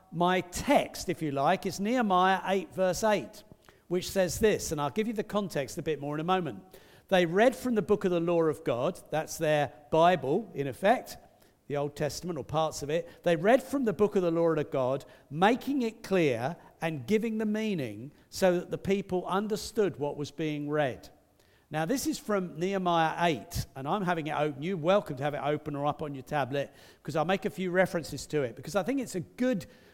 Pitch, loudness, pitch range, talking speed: 170 Hz, -30 LUFS, 150-195 Hz, 220 wpm